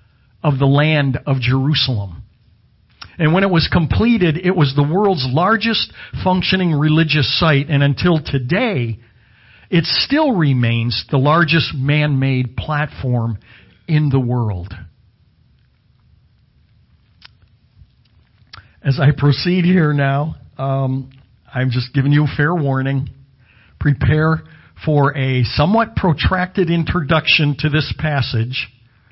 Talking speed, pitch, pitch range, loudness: 110 wpm, 140 Hz, 120-155 Hz, -16 LUFS